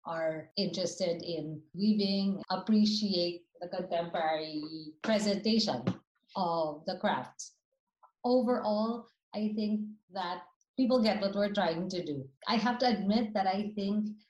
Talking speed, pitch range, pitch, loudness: 120 wpm, 175-215 Hz, 195 Hz, -32 LUFS